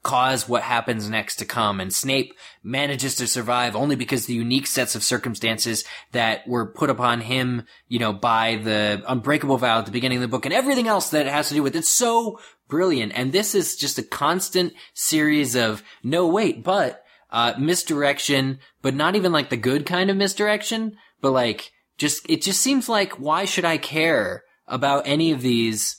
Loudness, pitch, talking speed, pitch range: -21 LUFS, 135 Hz, 195 wpm, 120-160 Hz